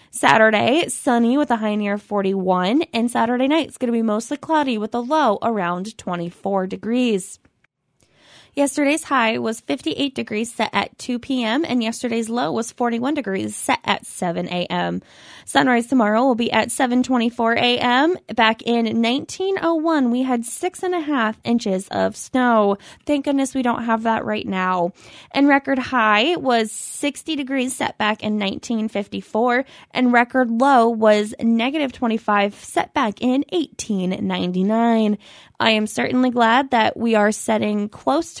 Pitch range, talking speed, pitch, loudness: 210-260 Hz, 165 wpm, 230 Hz, -20 LUFS